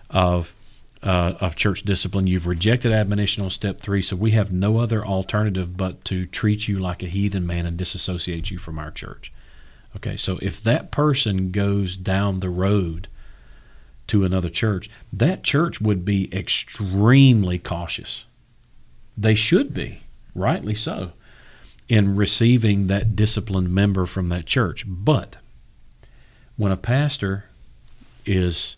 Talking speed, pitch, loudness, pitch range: 140 wpm, 95 Hz, -21 LUFS, 90-105 Hz